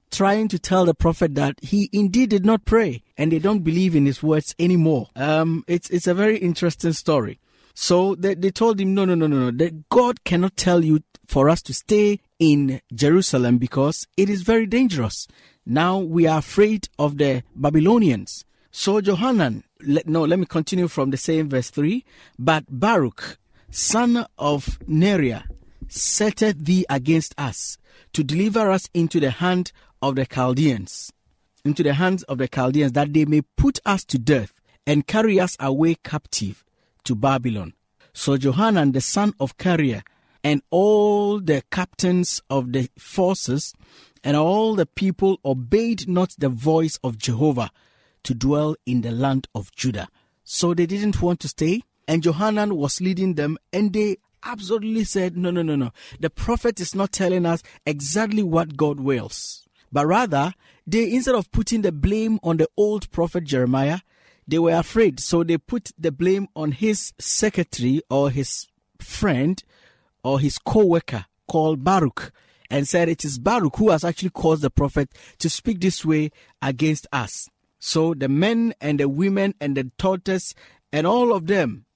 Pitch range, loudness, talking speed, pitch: 140-190 Hz, -21 LUFS, 170 wpm, 160 Hz